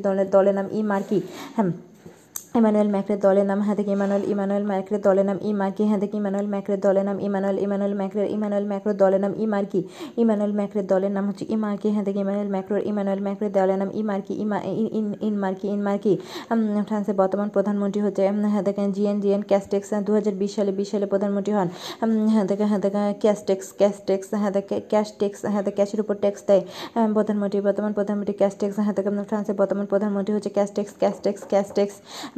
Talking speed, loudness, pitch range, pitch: 180 wpm, -23 LUFS, 195-210 Hz, 200 Hz